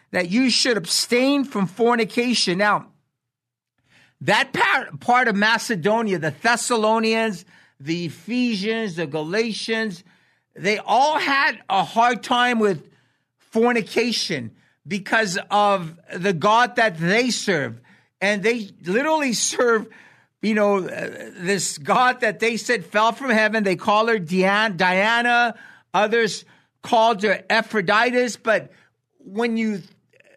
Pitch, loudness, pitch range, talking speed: 215 Hz, -20 LUFS, 190-235 Hz, 115 wpm